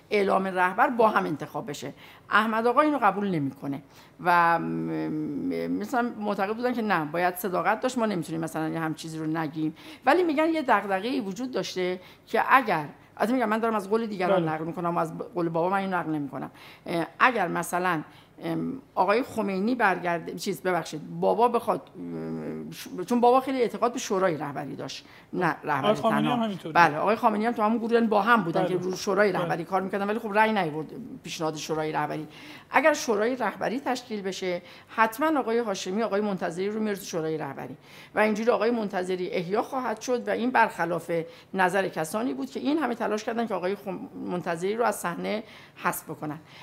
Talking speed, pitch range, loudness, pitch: 170 wpm, 165-225 Hz, -26 LUFS, 195 Hz